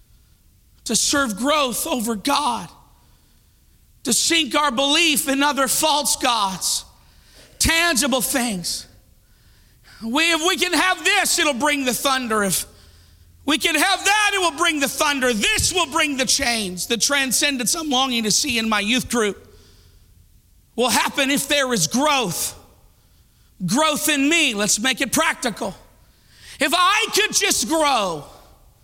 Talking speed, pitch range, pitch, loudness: 140 wpm, 215-310 Hz, 270 Hz, -18 LUFS